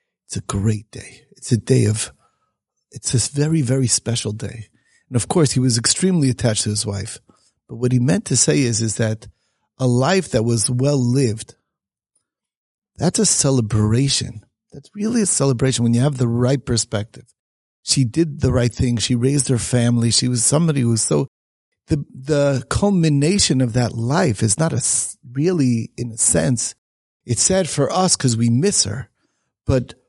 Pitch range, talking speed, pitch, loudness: 115-145 Hz, 175 wpm, 125 Hz, -18 LUFS